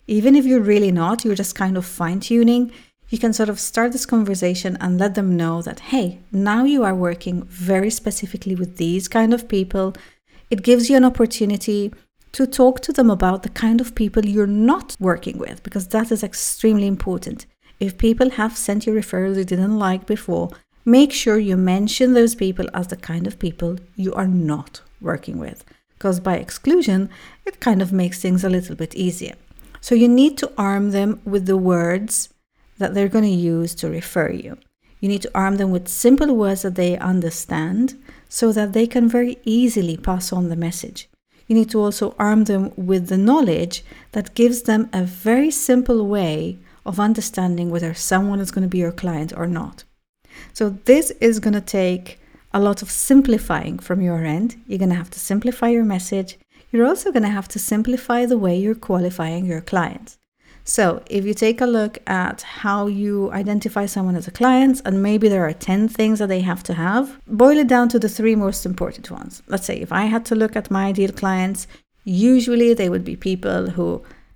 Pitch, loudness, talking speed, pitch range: 205 Hz, -19 LUFS, 200 wpm, 185-230 Hz